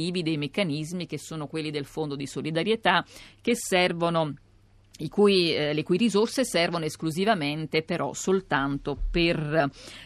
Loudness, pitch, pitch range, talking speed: -26 LUFS, 160 Hz, 145-180 Hz, 130 wpm